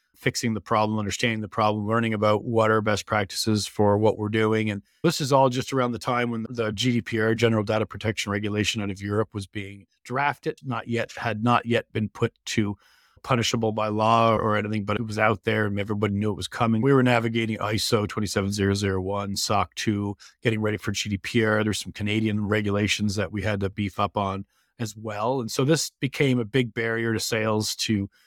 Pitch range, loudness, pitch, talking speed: 105-115 Hz, -25 LUFS, 110 Hz, 200 wpm